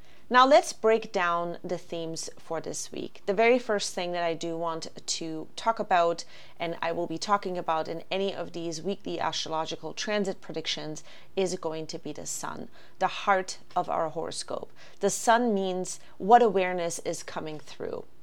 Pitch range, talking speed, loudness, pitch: 165-200 Hz, 175 wpm, -28 LUFS, 180 Hz